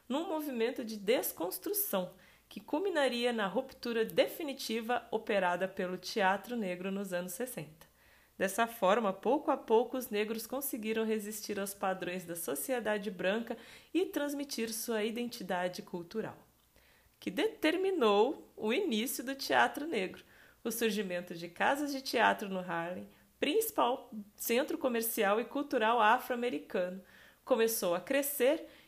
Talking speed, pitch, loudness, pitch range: 125 wpm, 225 Hz, -34 LUFS, 195-265 Hz